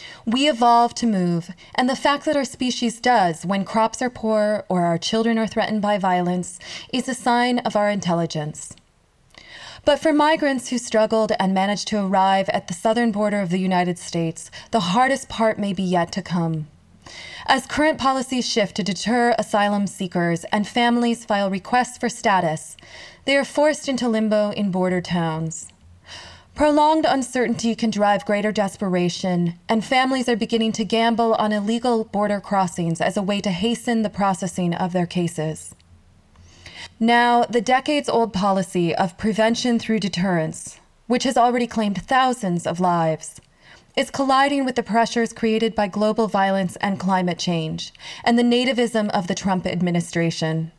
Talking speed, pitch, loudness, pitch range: 160 wpm, 210 Hz, -21 LUFS, 180-240 Hz